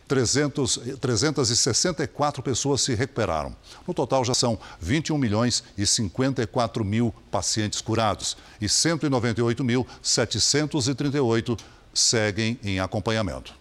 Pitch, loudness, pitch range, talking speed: 120 Hz, -24 LUFS, 110-135 Hz, 90 wpm